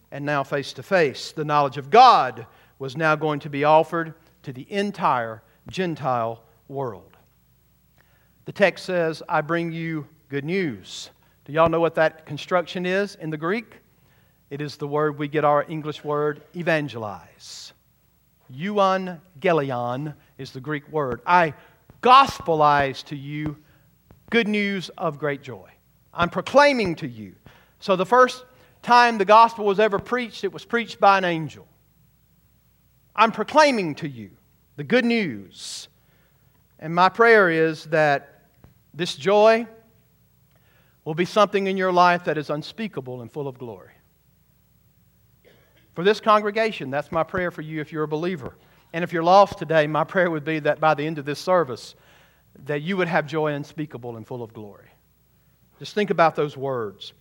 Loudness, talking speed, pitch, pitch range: -21 LUFS, 160 wpm, 155 Hz, 145-185 Hz